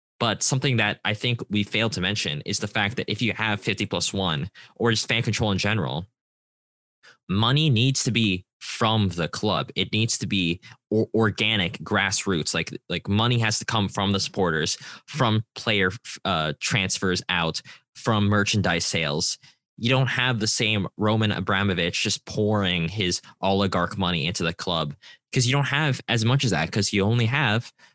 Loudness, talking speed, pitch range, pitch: -24 LUFS, 175 wpm, 95-115 Hz, 105 Hz